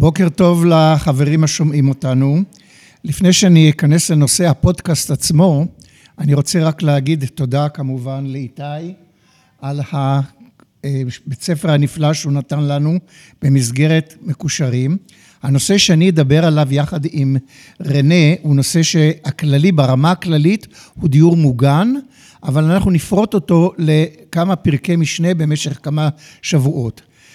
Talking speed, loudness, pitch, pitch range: 115 wpm, -14 LUFS, 155 Hz, 140-170 Hz